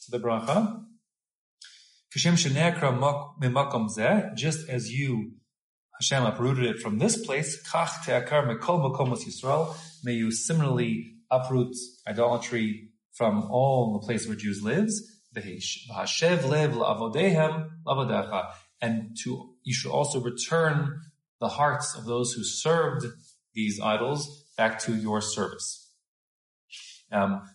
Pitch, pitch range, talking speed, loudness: 125 Hz, 115-155 Hz, 90 wpm, -27 LUFS